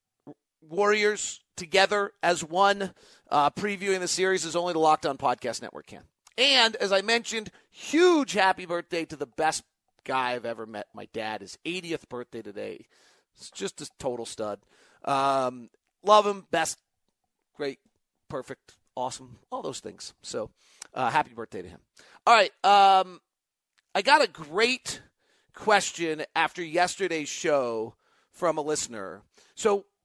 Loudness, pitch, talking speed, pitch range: -26 LUFS, 175 Hz, 140 wpm, 145-200 Hz